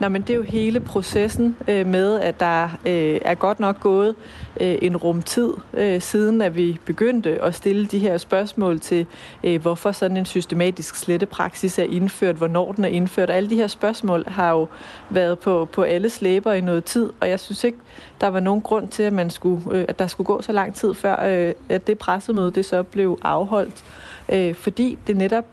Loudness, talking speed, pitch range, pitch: -21 LUFS, 210 wpm, 175-210 Hz, 190 Hz